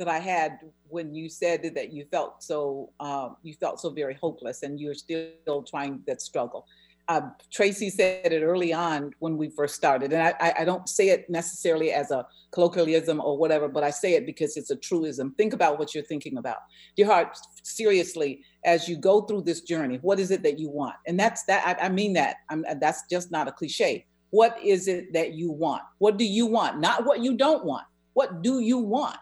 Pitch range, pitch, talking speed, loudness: 150-195 Hz, 165 Hz, 215 wpm, -26 LUFS